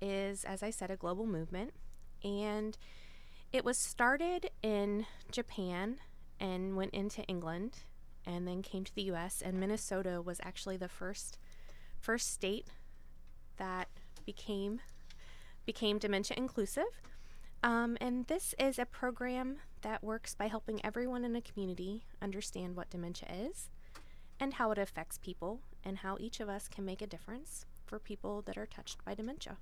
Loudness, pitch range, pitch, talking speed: -40 LUFS, 190-235 Hz, 205 Hz, 150 wpm